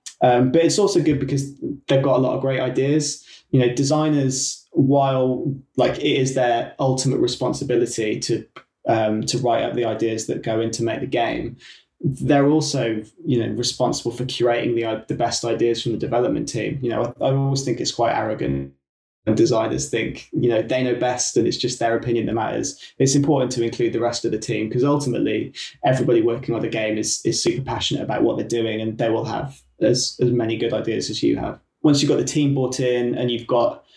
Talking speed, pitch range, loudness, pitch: 215 wpm, 115-135 Hz, -21 LUFS, 125 Hz